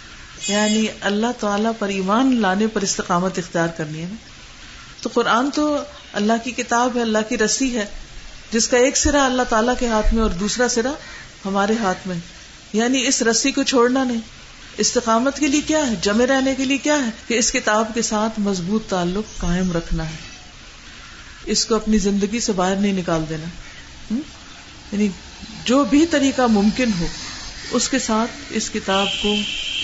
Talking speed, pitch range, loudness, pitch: 170 wpm, 200-250 Hz, -19 LUFS, 220 Hz